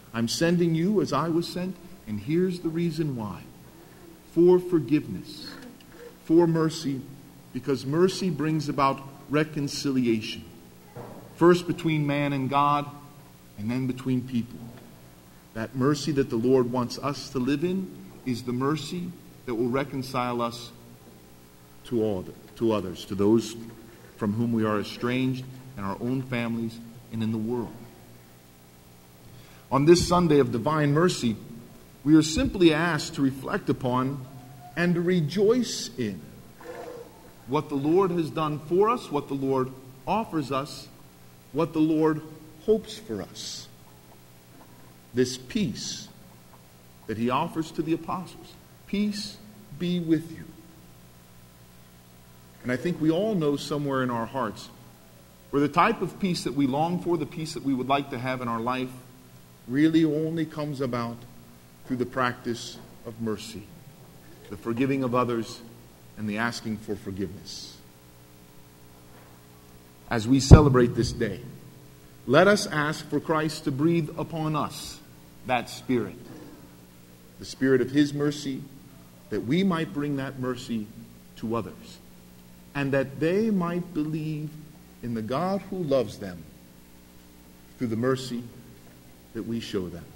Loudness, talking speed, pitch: -26 LUFS, 140 wpm, 130 Hz